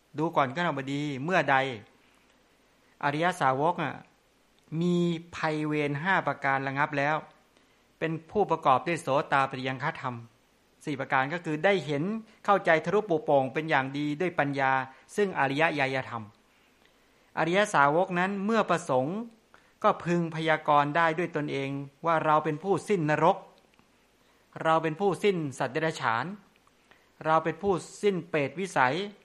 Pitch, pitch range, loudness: 155 Hz, 140-175 Hz, -28 LUFS